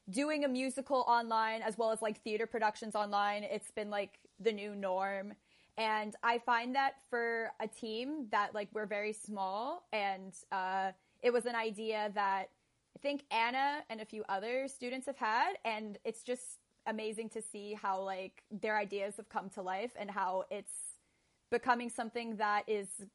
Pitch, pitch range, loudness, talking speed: 220 Hz, 205-235 Hz, -37 LUFS, 175 wpm